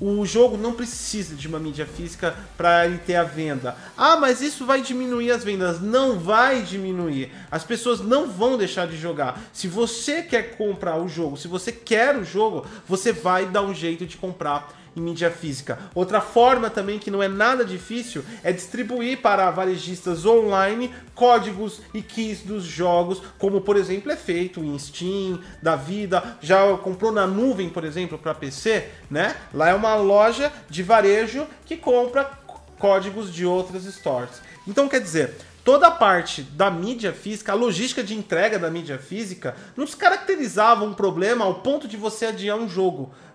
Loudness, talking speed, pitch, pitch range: -22 LUFS, 175 wpm, 200 Hz, 175-235 Hz